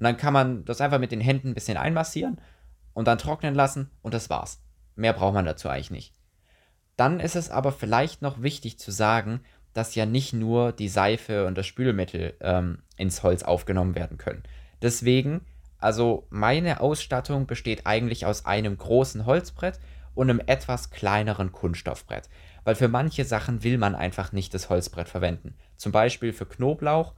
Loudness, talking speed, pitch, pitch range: -26 LUFS, 175 wpm, 110 Hz, 90-130 Hz